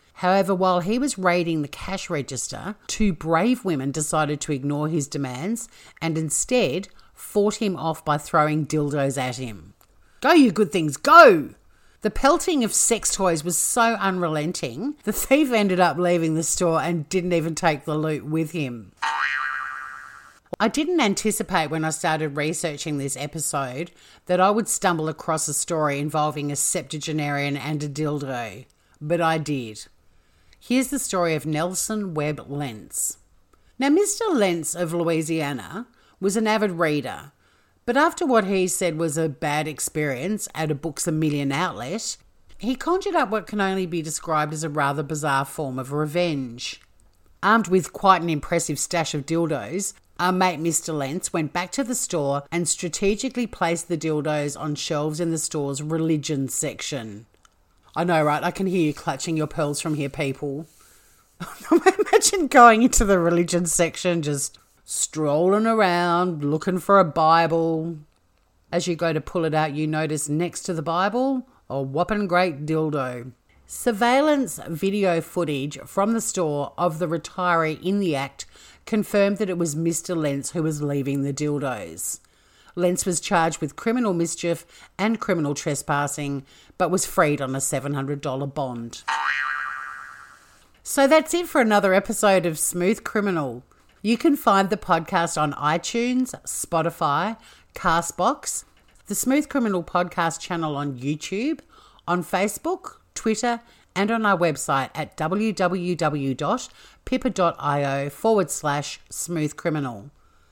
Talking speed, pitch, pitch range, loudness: 150 wpm, 165 Hz, 145-195 Hz, -23 LUFS